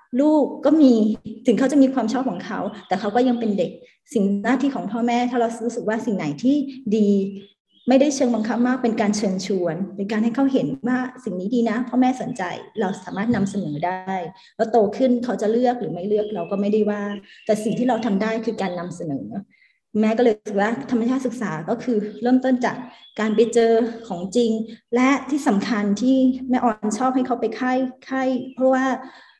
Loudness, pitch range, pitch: -21 LUFS, 210-250 Hz, 230 Hz